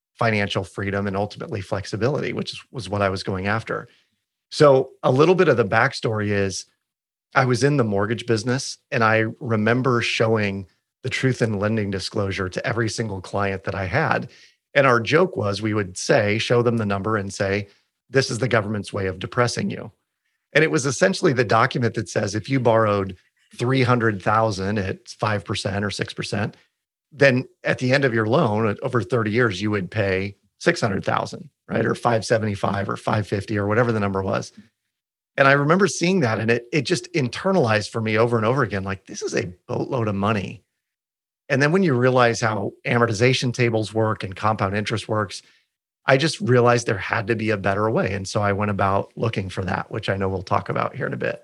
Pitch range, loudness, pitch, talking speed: 100-125 Hz, -21 LUFS, 110 Hz, 195 wpm